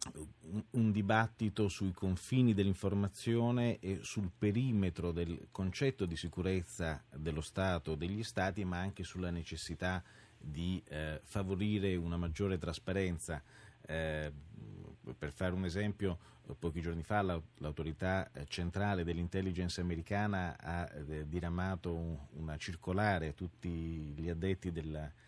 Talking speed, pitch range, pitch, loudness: 115 wpm, 80-100 Hz, 90 Hz, -38 LUFS